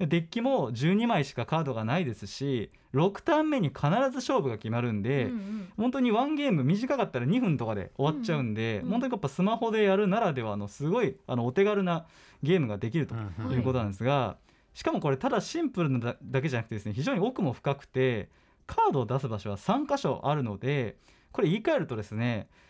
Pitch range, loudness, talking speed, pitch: 120-200 Hz, -29 LUFS, 410 characters per minute, 140 Hz